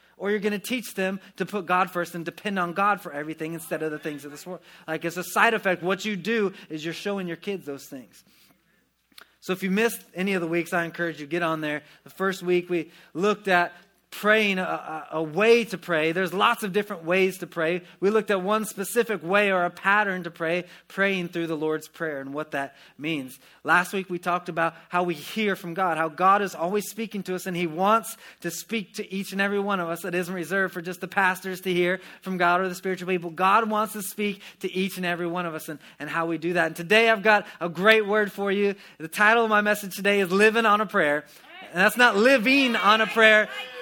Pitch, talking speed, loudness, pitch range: 185 Hz, 245 wpm, -24 LUFS, 170-205 Hz